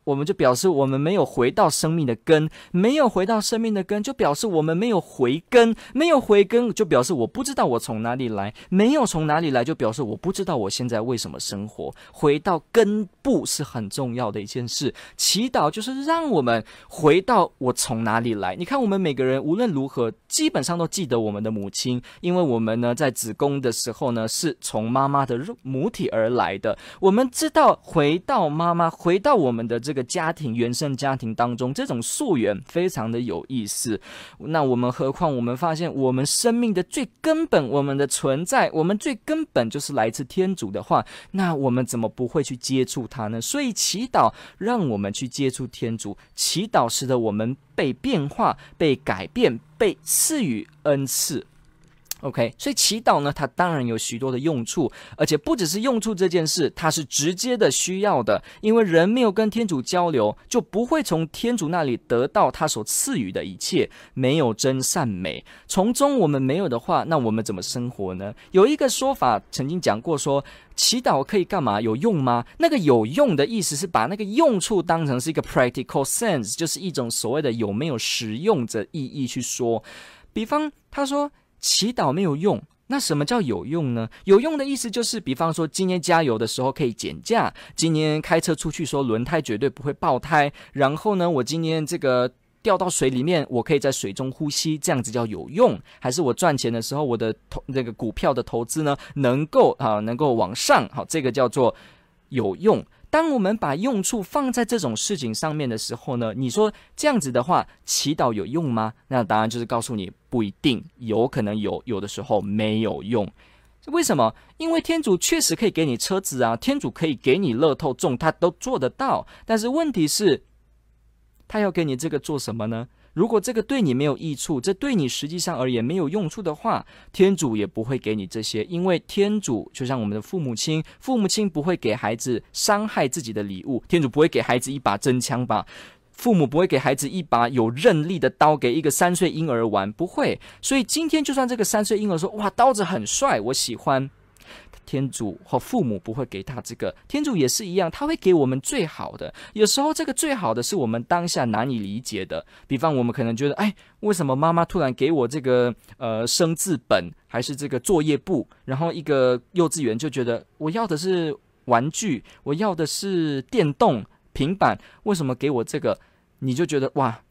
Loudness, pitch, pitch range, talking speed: -22 LUFS, 150 Hz, 125-195 Hz, 300 characters per minute